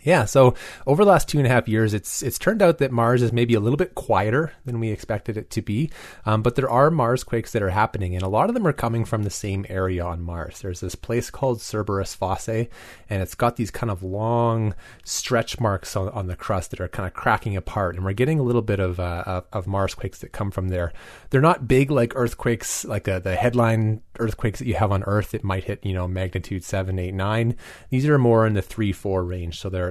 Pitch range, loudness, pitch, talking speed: 95-120 Hz, -23 LUFS, 110 Hz, 250 wpm